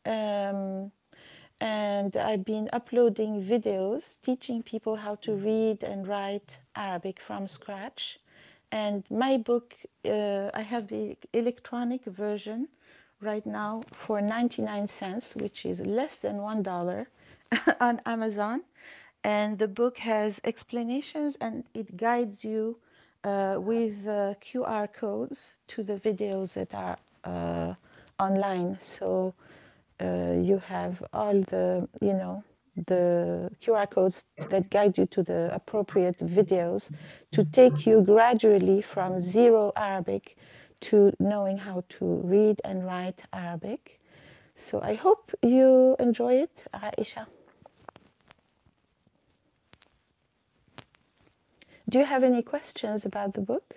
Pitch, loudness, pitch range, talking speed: 210 Hz, -28 LUFS, 195-235 Hz, 120 wpm